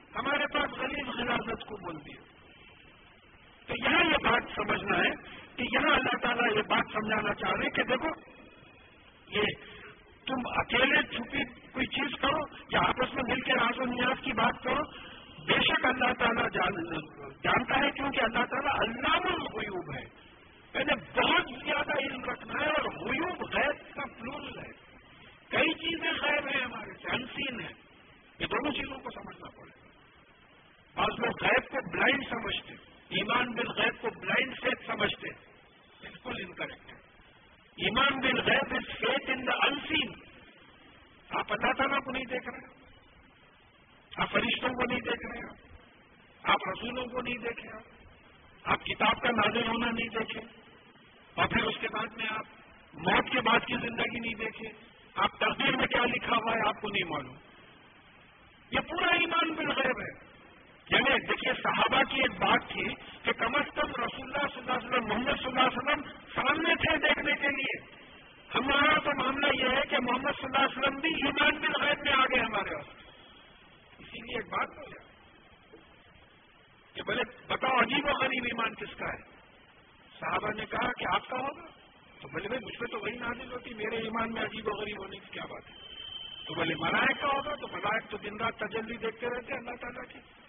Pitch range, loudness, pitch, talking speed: 225-275 Hz, -30 LUFS, 245 Hz, 170 wpm